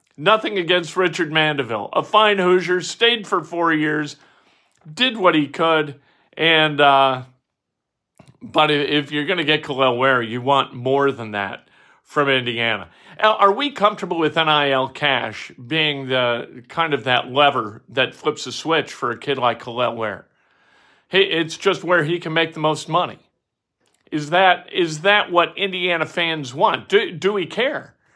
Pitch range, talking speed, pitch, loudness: 135-175 Hz, 160 wpm, 155 Hz, -19 LUFS